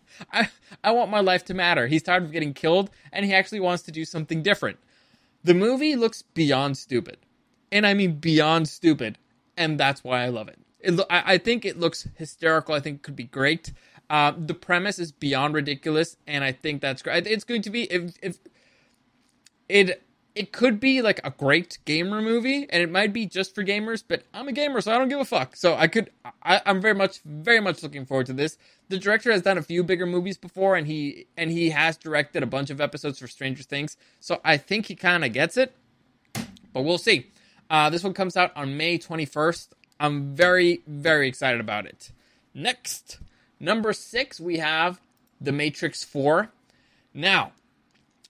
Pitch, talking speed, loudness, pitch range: 170 Hz, 200 wpm, -23 LUFS, 150-200 Hz